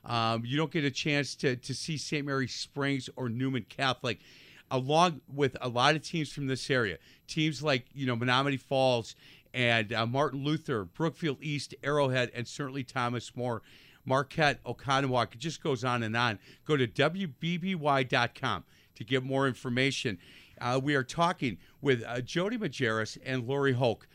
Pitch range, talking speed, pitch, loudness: 125-145 Hz, 165 wpm, 135 Hz, -31 LUFS